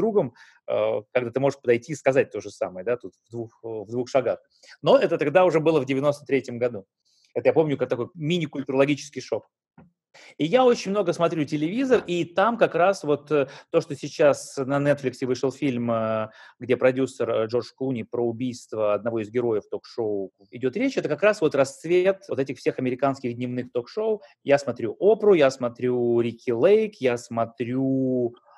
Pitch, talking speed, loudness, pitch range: 135 Hz, 170 wpm, -24 LUFS, 120-155 Hz